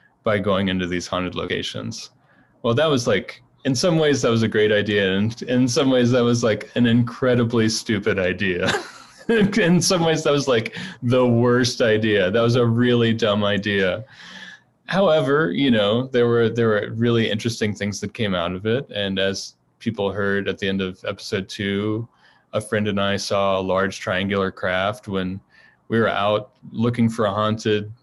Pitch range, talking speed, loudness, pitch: 100-120 Hz, 185 wpm, -20 LUFS, 110 Hz